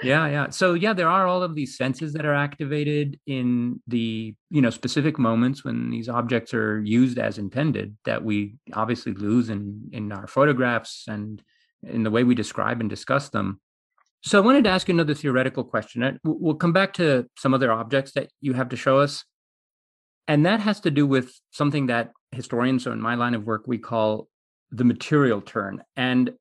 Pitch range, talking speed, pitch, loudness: 115-145 Hz, 195 wpm, 125 Hz, -23 LUFS